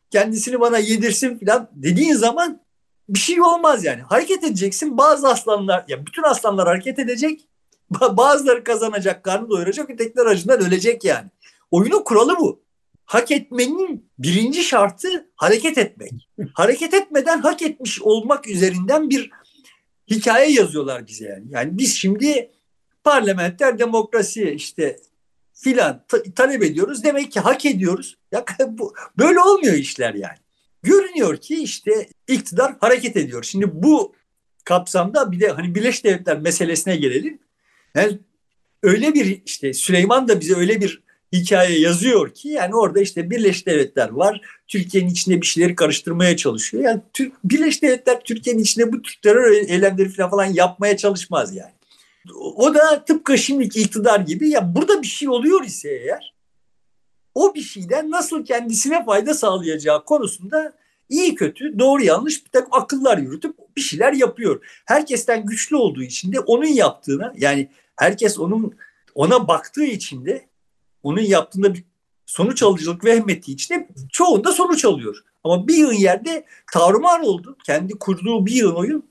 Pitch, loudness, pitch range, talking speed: 235 Hz, -18 LUFS, 195-300 Hz, 145 wpm